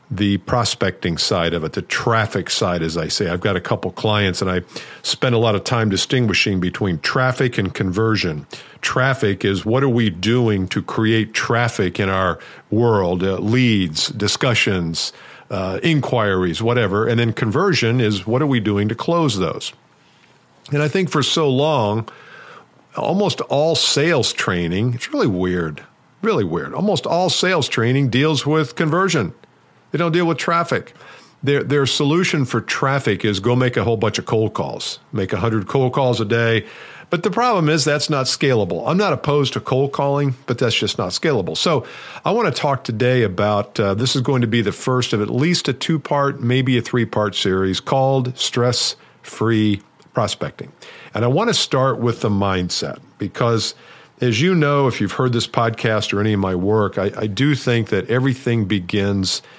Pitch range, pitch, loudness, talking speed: 105-135 Hz, 120 Hz, -18 LUFS, 180 wpm